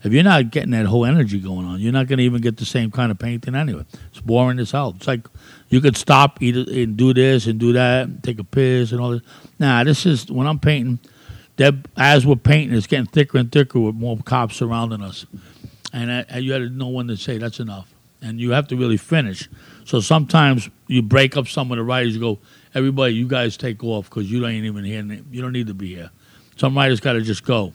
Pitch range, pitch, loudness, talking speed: 115-135 Hz, 125 Hz, -18 LUFS, 240 wpm